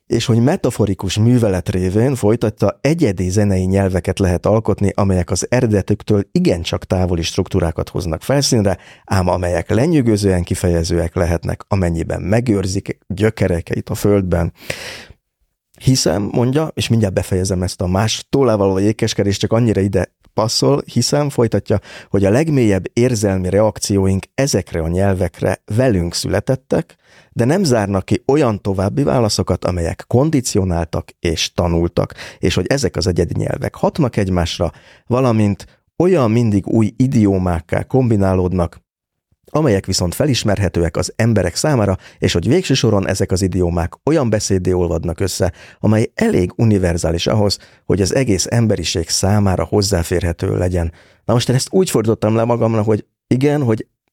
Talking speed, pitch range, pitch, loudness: 130 wpm, 90-115 Hz, 100 Hz, -17 LUFS